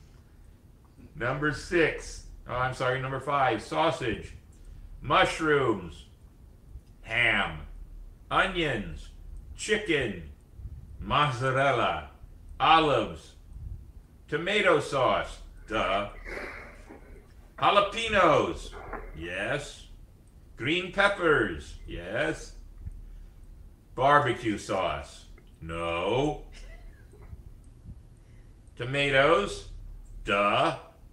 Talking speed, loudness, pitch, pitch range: 50 wpm, -27 LUFS, 100 Hz, 80-130 Hz